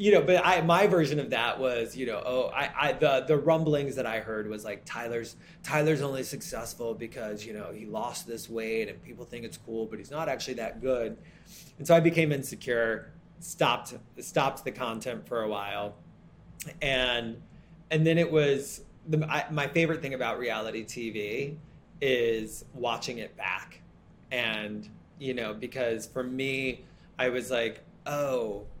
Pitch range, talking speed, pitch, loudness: 115-155 Hz, 175 wpm, 130 Hz, -29 LUFS